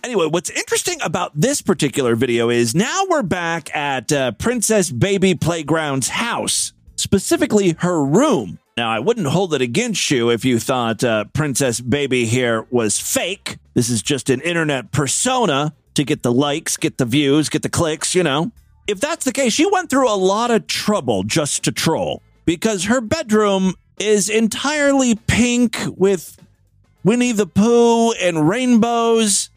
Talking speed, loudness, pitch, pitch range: 160 wpm, -17 LUFS, 175 Hz, 135-225 Hz